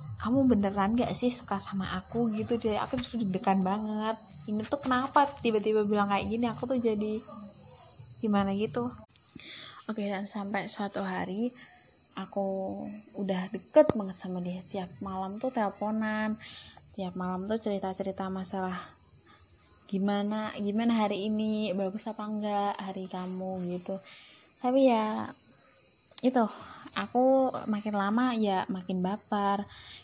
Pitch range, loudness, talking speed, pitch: 190-220 Hz, -30 LUFS, 130 wpm, 205 Hz